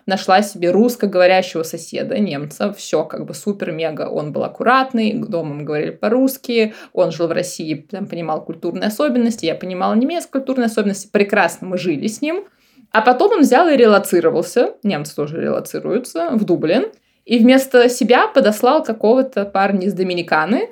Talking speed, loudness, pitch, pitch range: 155 wpm, -17 LUFS, 205 Hz, 175-245 Hz